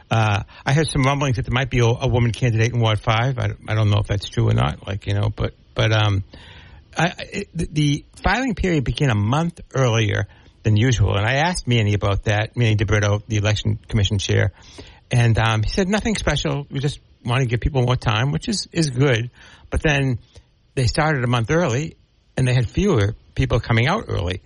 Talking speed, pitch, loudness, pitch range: 215 wpm, 120 Hz, -20 LUFS, 105-140 Hz